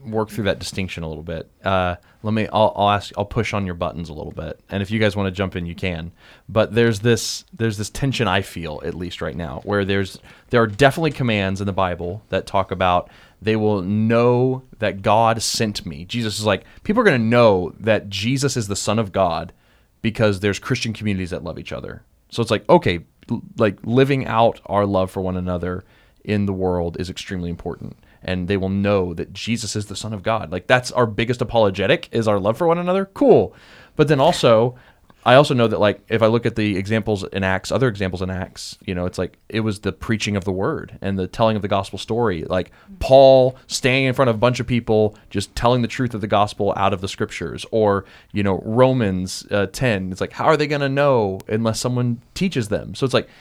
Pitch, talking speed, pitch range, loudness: 105 Hz, 230 wpm, 95-115 Hz, -20 LUFS